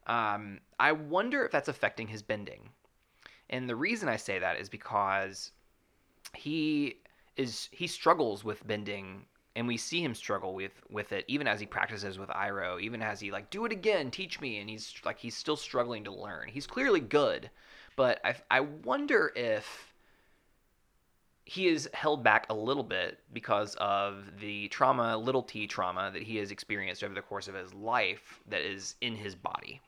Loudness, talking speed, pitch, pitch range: -33 LUFS, 180 wpm, 110 Hz, 100-145 Hz